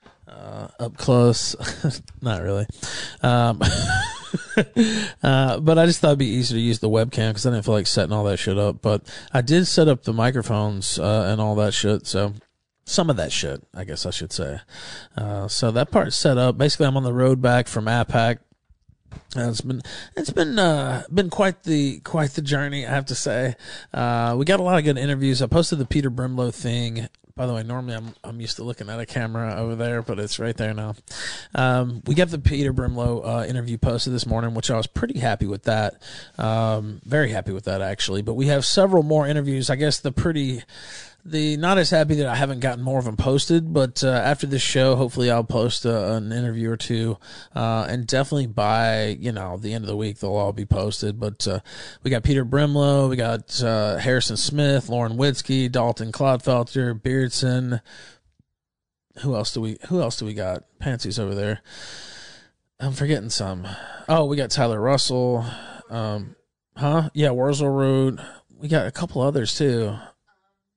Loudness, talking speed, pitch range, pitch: -22 LUFS, 200 wpm, 110-140 Hz, 120 Hz